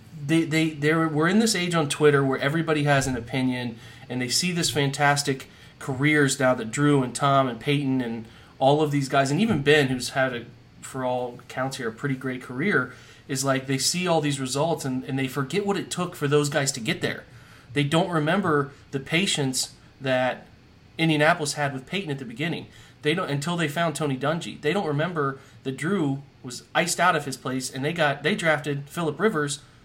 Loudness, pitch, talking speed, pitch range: -24 LUFS, 140 Hz, 205 wpm, 130-155 Hz